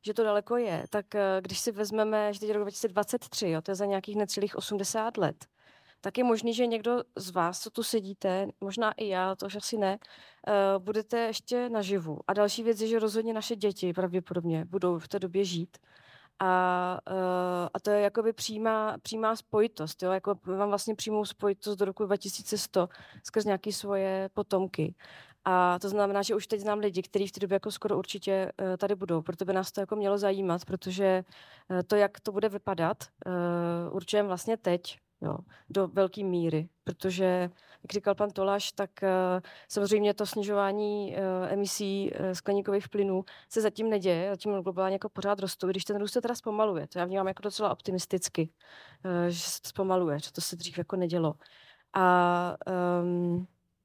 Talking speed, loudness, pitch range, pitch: 175 wpm, -30 LUFS, 185-210 Hz, 195 Hz